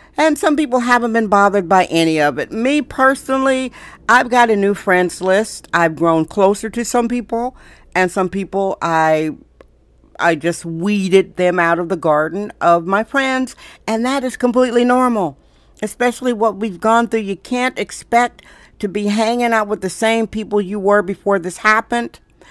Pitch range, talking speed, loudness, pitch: 185-245 Hz, 175 wpm, -16 LUFS, 210 Hz